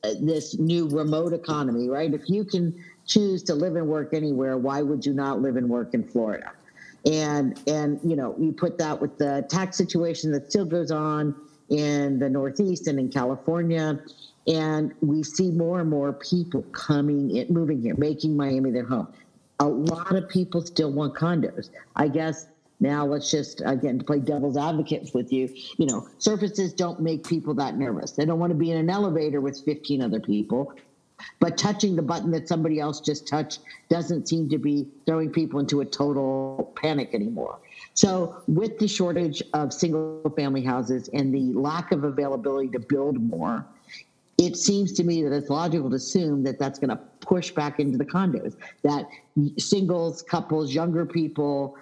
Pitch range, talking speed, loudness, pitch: 140-170 Hz, 180 wpm, -25 LUFS, 155 Hz